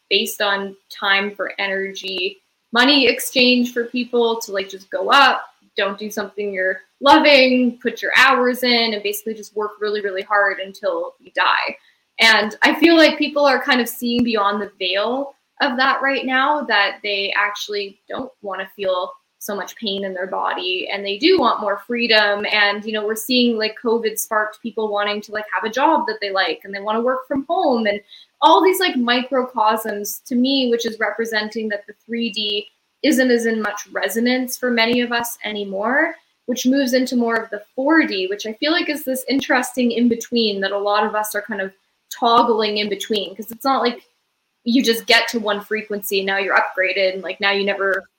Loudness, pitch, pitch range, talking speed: -18 LUFS, 220 Hz, 205-255 Hz, 200 wpm